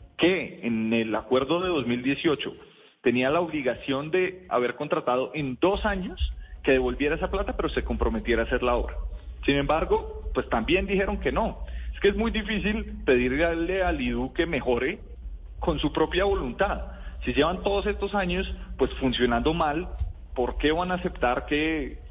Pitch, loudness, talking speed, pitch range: 145 Hz, -26 LUFS, 165 wpm, 115-185 Hz